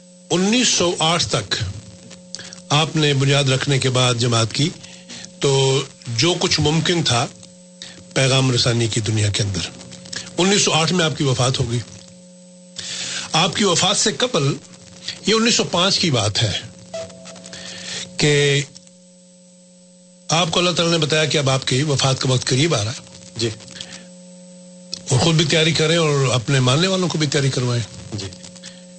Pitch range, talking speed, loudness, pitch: 125-180 Hz, 145 wpm, -18 LUFS, 150 Hz